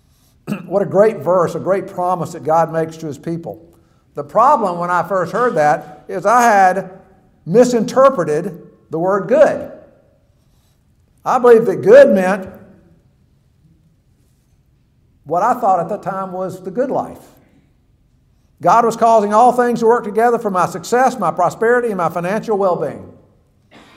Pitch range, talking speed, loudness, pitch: 175-230 Hz, 150 wpm, -15 LUFS, 190 Hz